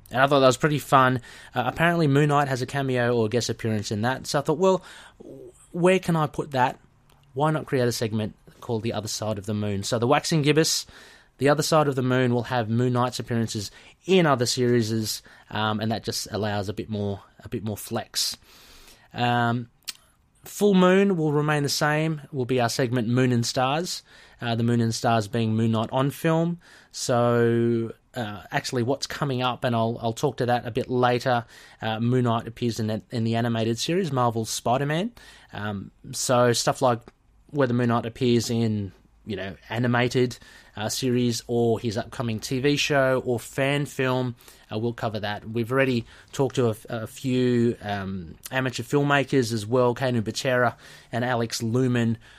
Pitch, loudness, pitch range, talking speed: 125 Hz, -24 LUFS, 115-135 Hz, 190 wpm